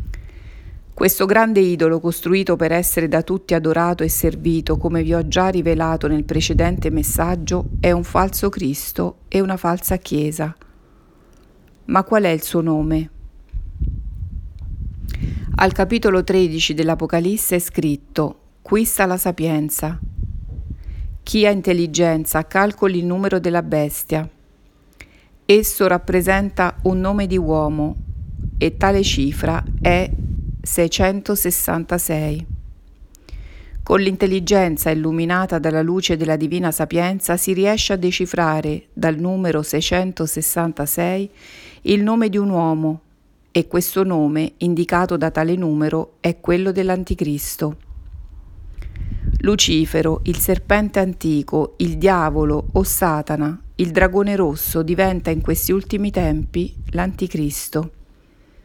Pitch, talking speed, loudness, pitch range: 165 Hz, 110 wpm, -19 LUFS, 150-185 Hz